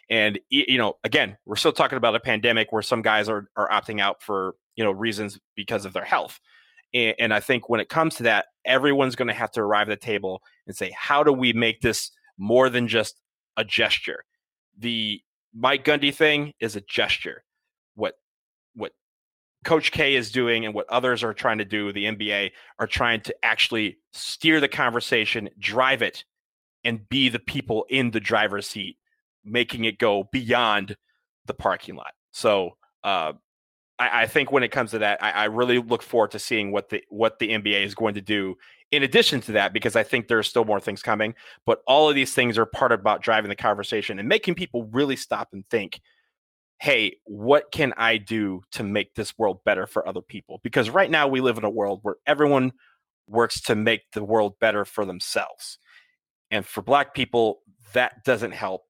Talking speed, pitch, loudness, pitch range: 200 wpm, 115 Hz, -23 LUFS, 105-135 Hz